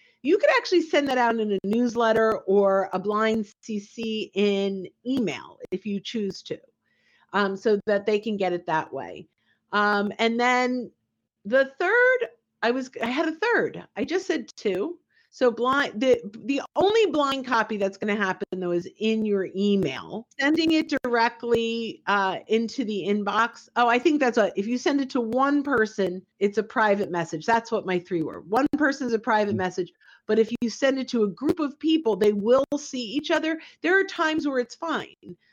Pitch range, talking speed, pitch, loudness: 205-275 Hz, 190 wpm, 230 Hz, -24 LUFS